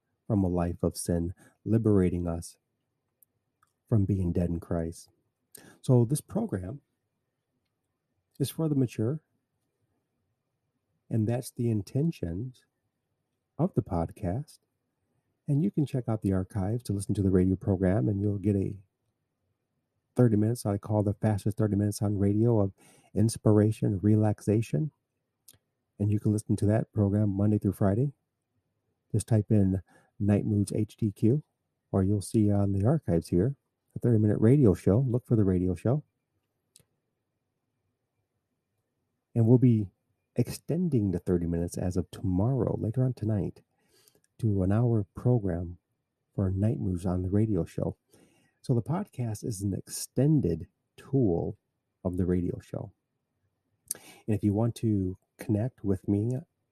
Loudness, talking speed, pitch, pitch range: -28 LUFS, 140 wpm, 110 Hz, 100-125 Hz